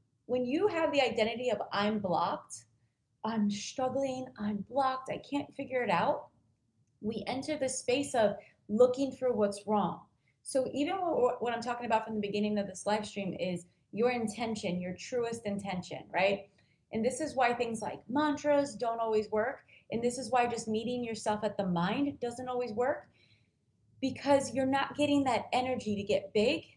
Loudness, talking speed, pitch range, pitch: -33 LUFS, 175 wpm, 205-260 Hz, 235 Hz